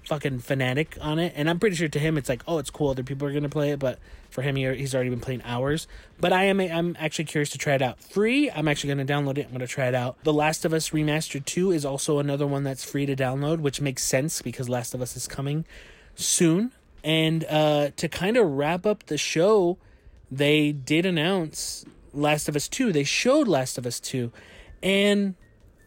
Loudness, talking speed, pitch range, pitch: -25 LUFS, 225 wpm, 130-165 Hz, 145 Hz